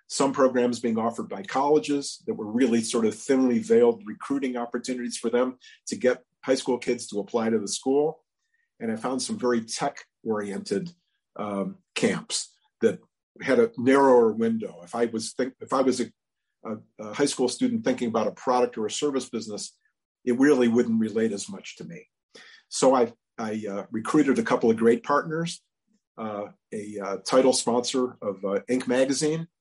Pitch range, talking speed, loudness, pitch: 115-150 Hz, 180 wpm, -25 LUFS, 125 Hz